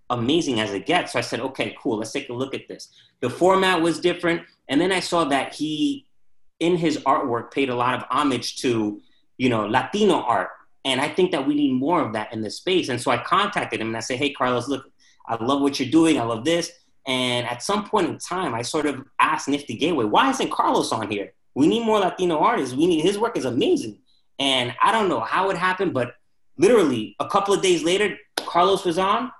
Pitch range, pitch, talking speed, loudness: 125-185 Hz, 155 Hz, 235 wpm, -22 LUFS